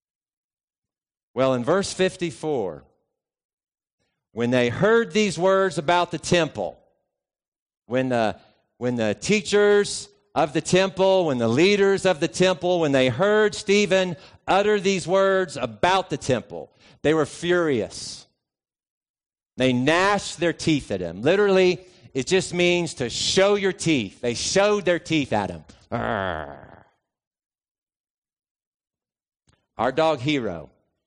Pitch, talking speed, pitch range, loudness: 170 Hz, 120 wpm, 125-190 Hz, -22 LUFS